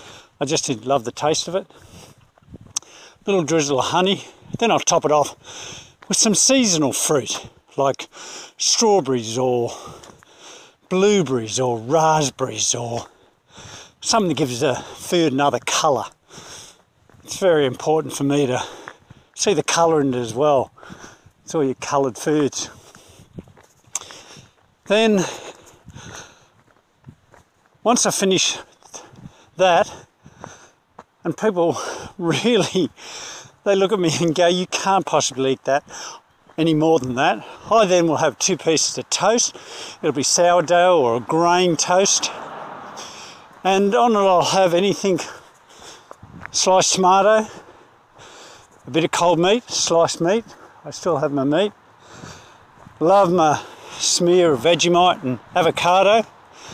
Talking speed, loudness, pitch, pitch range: 125 wpm, -18 LUFS, 165 Hz, 145-190 Hz